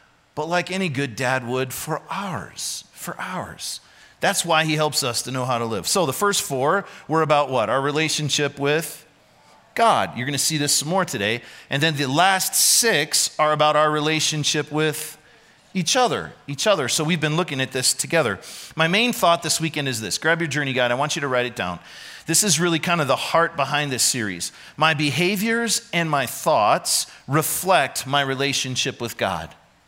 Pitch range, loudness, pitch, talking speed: 135-165 Hz, -21 LUFS, 150 Hz, 195 wpm